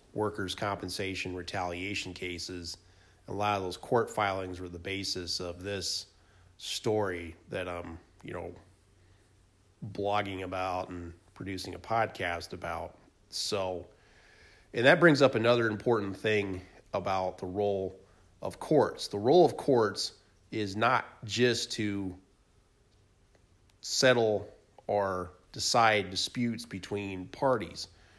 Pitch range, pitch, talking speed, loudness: 90-105 Hz, 95 Hz, 115 wpm, -30 LUFS